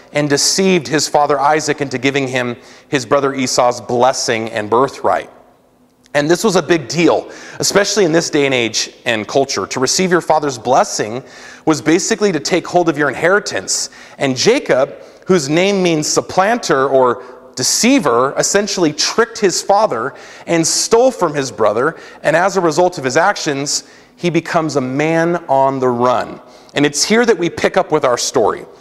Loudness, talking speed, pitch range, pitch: -14 LUFS, 170 wpm, 135-180 Hz, 155 Hz